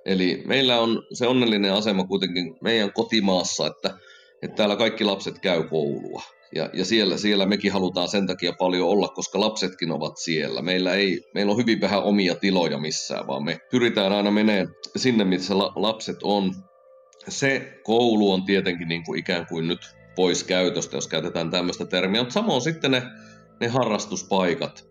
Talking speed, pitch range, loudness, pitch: 170 wpm, 90-110 Hz, -23 LUFS, 100 Hz